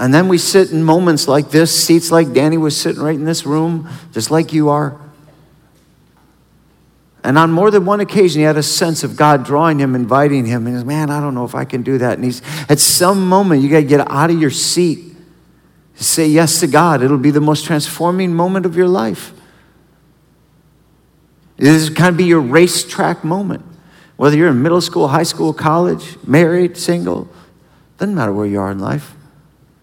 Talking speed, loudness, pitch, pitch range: 195 wpm, -13 LUFS, 155 Hz, 145-170 Hz